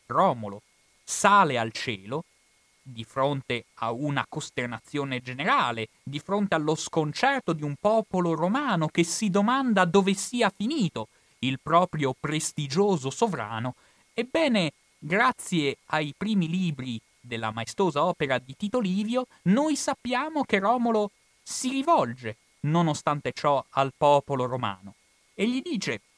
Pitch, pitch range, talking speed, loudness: 160 Hz, 130-205 Hz, 120 wpm, -26 LUFS